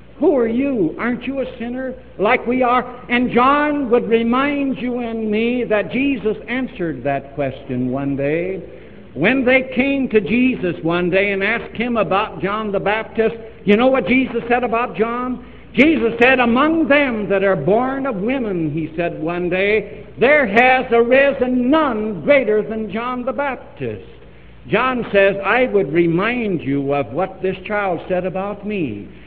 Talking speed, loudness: 165 wpm, -17 LUFS